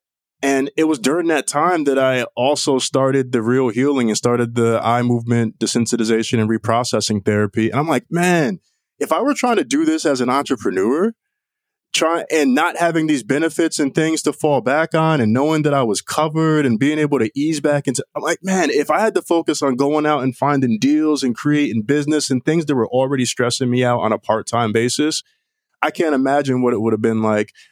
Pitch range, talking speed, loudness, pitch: 120-155 Hz, 215 wpm, -17 LUFS, 140 Hz